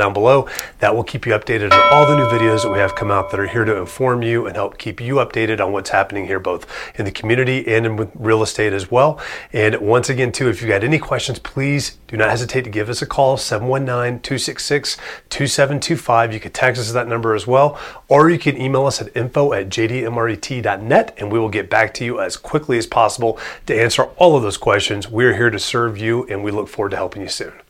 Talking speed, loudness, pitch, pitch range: 235 wpm, -17 LUFS, 120 Hz, 110-135 Hz